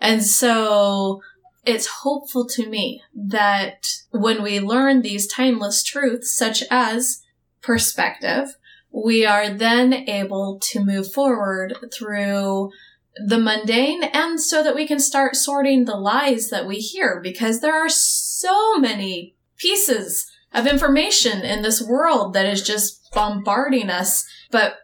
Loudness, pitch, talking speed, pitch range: -19 LUFS, 230 Hz, 135 wpm, 205-275 Hz